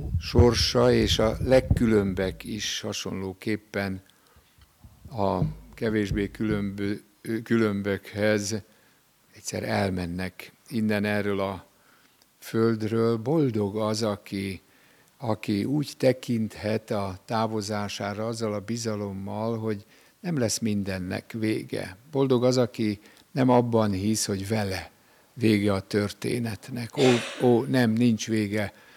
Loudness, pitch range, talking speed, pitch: -26 LUFS, 100-115 Hz, 100 wpm, 110 Hz